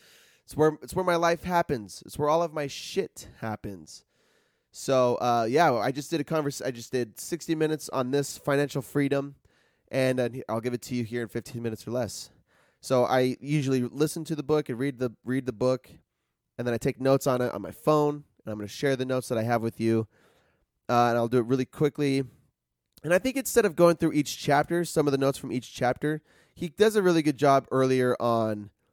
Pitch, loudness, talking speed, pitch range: 135 Hz, -27 LUFS, 225 wpm, 120-150 Hz